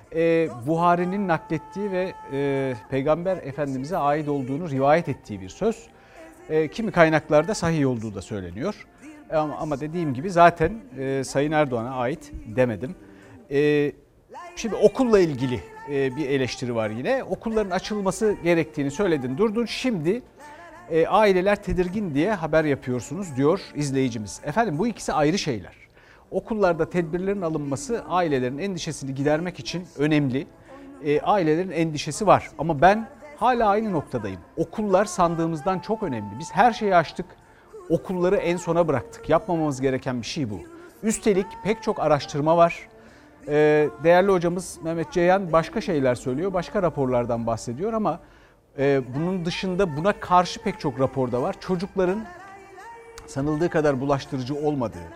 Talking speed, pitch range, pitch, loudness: 125 wpm, 140-190 Hz, 160 Hz, -24 LUFS